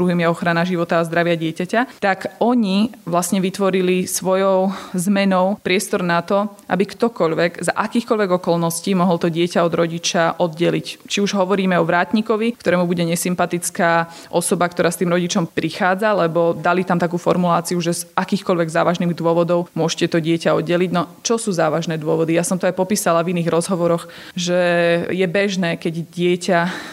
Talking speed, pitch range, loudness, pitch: 165 wpm, 170-190 Hz, -18 LUFS, 175 Hz